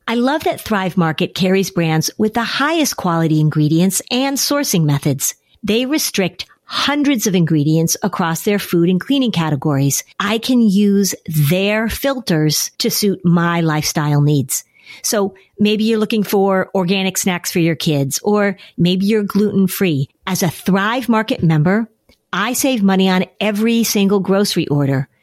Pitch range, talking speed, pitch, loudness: 165-220 Hz, 150 wpm, 195 Hz, -16 LUFS